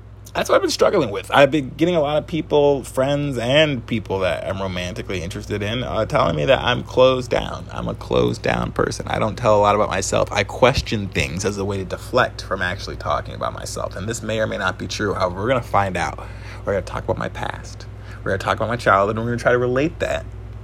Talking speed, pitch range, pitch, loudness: 260 wpm, 95-120 Hz, 105 Hz, -20 LUFS